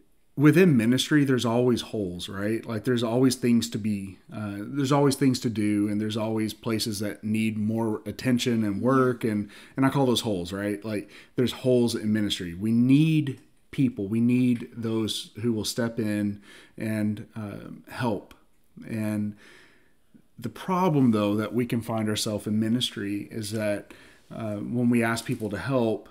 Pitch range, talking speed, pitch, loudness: 105-125 Hz, 170 wpm, 110 Hz, -26 LUFS